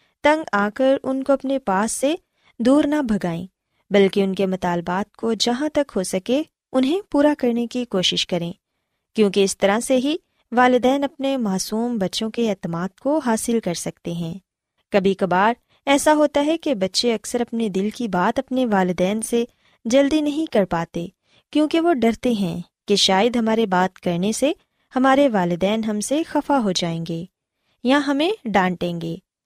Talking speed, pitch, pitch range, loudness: 170 wpm, 225 Hz, 190-275 Hz, -20 LUFS